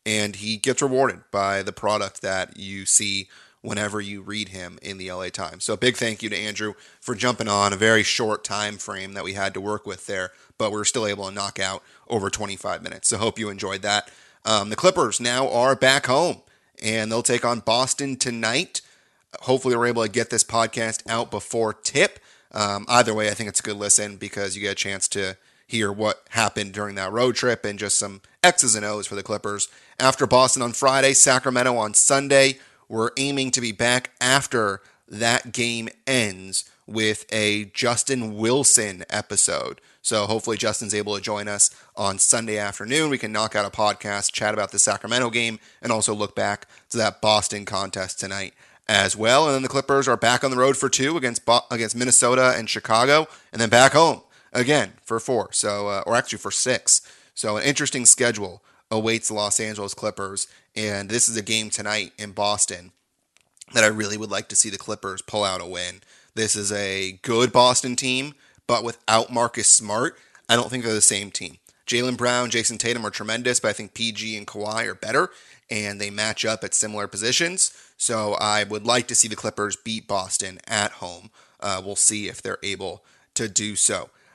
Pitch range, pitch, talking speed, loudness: 105-120 Hz, 110 Hz, 200 wpm, -21 LUFS